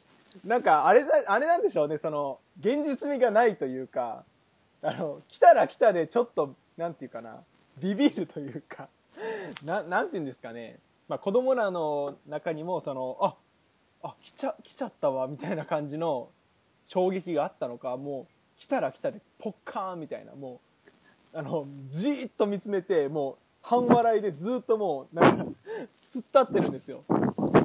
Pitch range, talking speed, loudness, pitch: 150-245 Hz, 335 characters per minute, -27 LUFS, 190 Hz